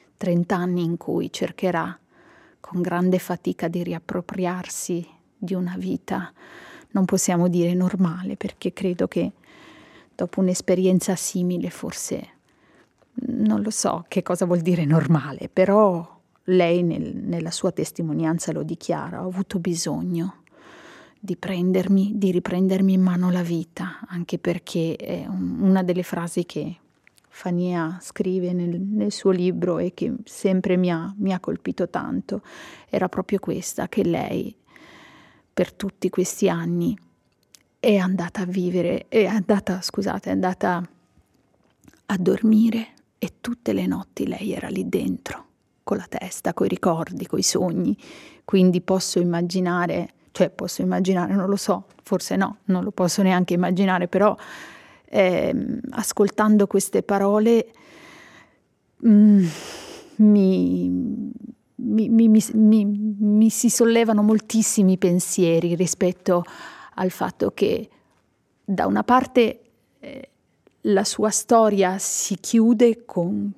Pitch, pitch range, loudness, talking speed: 190 Hz, 180-215 Hz, -22 LUFS, 125 wpm